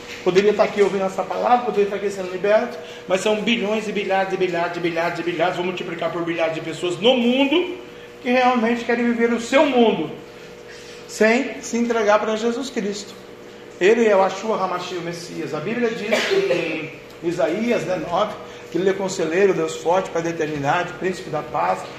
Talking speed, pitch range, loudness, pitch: 185 wpm, 170-220 Hz, -20 LUFS, 190 Hz